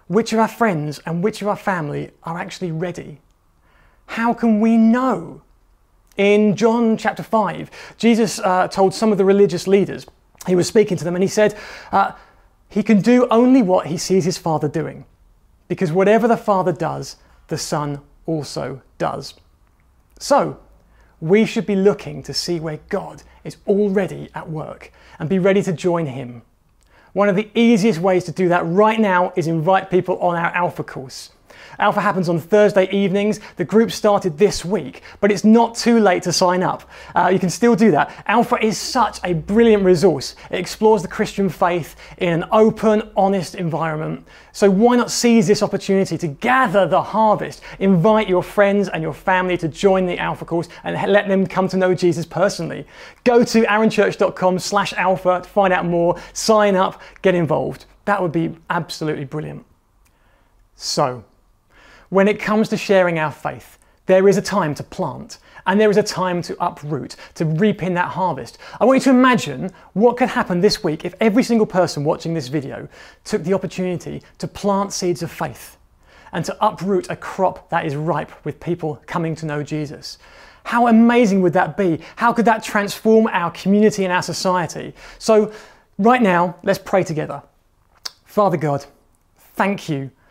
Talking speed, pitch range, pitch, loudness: 175 wpm, 165-210 Hz, 185 Hz, -18 LUFS